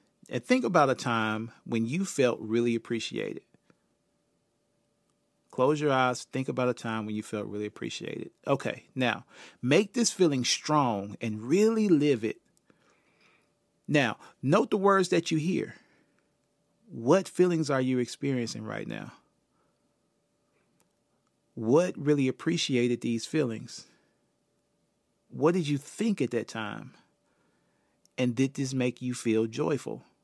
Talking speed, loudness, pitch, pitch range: 130 wpm, -28 LUFS, 130 Hz, 115-160 Hz